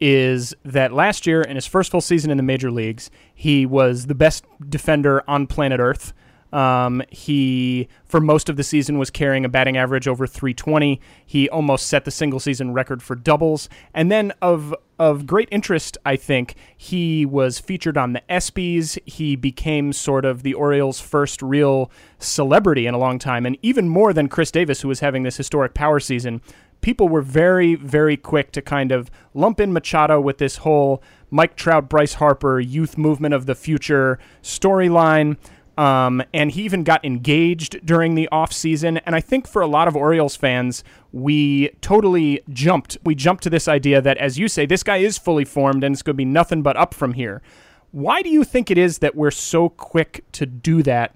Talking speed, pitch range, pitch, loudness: 195 wpm, 135-165 Hz, 145 Hz, -18 LUFS